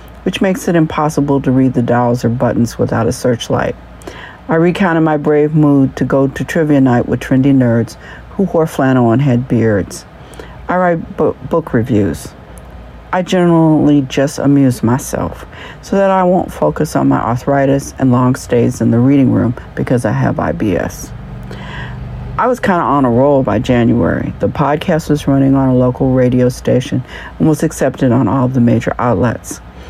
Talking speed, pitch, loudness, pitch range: 175 wpm, 135 Hz, -13 LUFS, 120-150 Hz